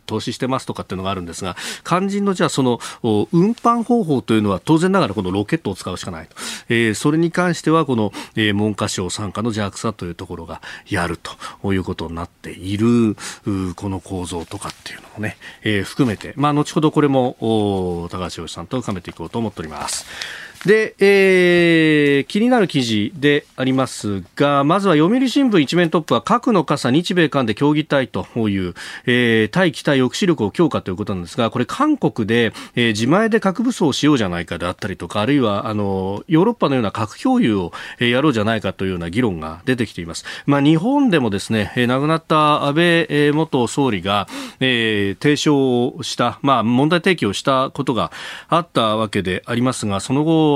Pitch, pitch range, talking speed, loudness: 125 Hz, 100-155 Hz, 395 characters per minute, -18 LUFS